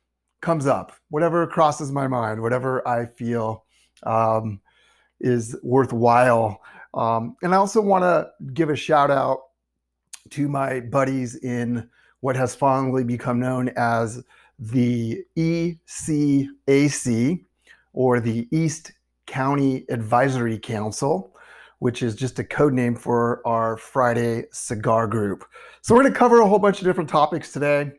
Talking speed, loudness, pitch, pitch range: 135 wpm, -22 LUFS, 125 Hz, 115-145 Hz